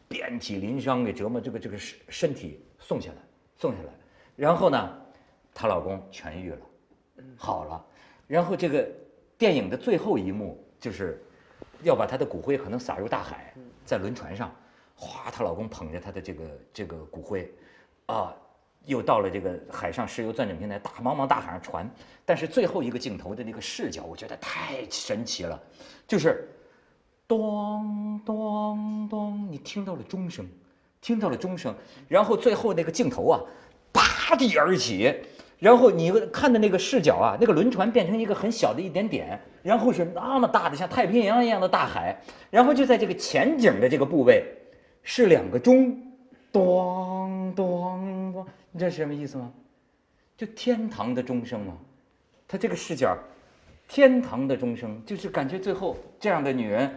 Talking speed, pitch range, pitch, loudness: 255 characters per minute, 170-245 Hz, 205 Hz, -25 LUFS